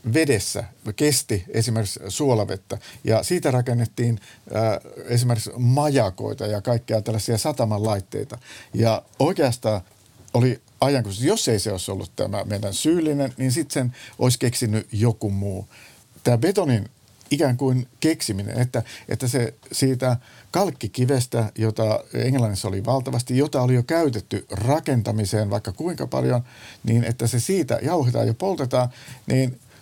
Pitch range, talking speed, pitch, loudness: 110-130 Hz, 130 wpm, 120 Hz, -23 LUFS